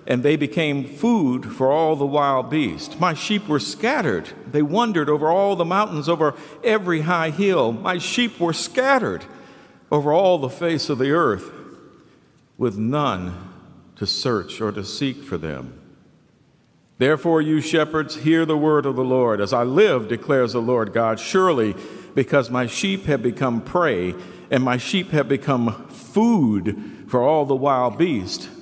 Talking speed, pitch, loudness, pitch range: 160 wpm, 150 Hz, -20 LUFS, 125-175 Hz